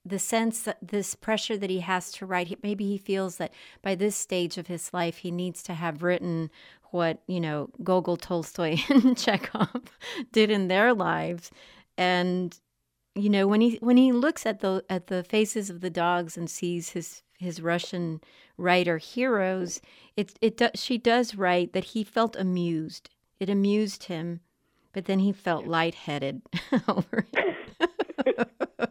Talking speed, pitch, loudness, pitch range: 165 wpm, 185 Hz, -27 LUFS, 175-215 Hz